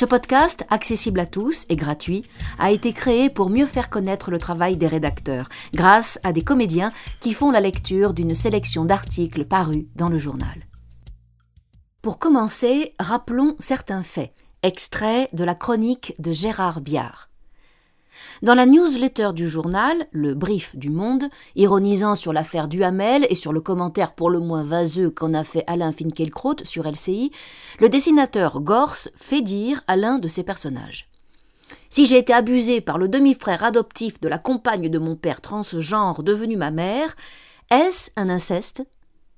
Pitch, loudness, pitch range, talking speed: 195 Hz, -20 LUFS, 165-245 Hz, 160 wpm